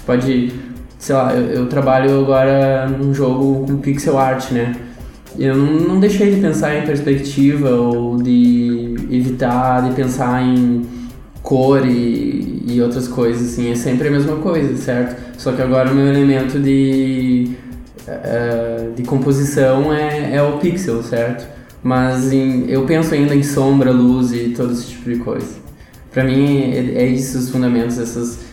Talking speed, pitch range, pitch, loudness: 160 wpm, 120-140 Hz, 130 Hz, -15 LUFS